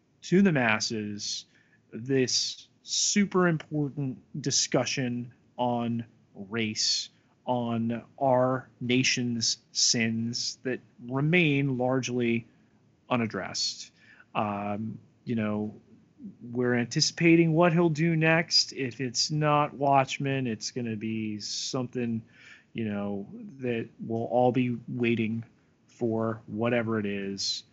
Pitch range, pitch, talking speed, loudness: 115-135 Hz, 120 Hz, 100 wpm, -28 LUFS